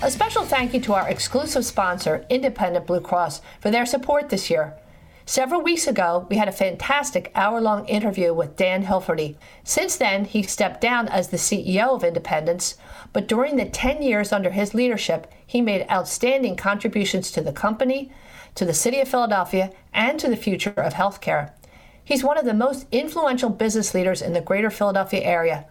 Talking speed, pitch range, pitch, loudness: 180 wpm, 185-255 Hz, 210 Hz, -22 LUFS